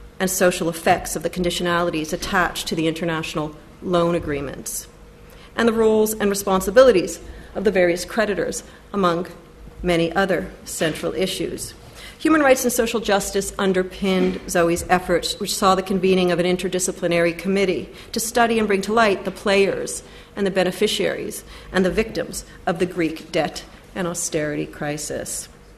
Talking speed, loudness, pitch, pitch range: 145 wpm, -21 LUFS, 185 Hz, 170-200 Hz